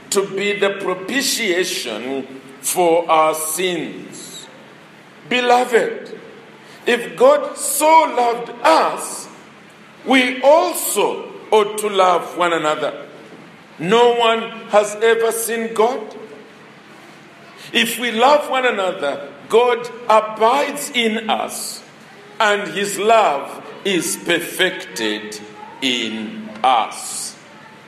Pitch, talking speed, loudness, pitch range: 225 Hz, 90 wpm, -17 LUFS, 185-255 Hz